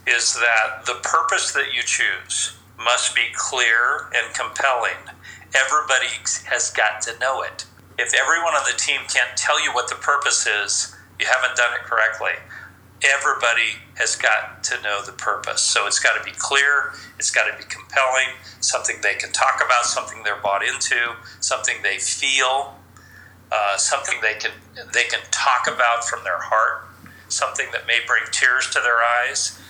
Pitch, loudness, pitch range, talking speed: 115 Hz, -19 LUFS, 95-120 Hz, 170 wpm